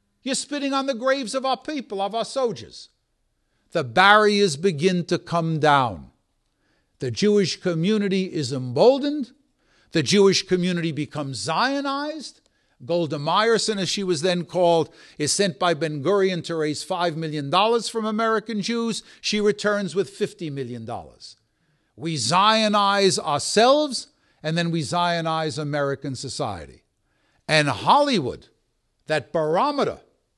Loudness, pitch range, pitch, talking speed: -22 LUFS, 155-220 Hz, 185 Hz, 125 wpm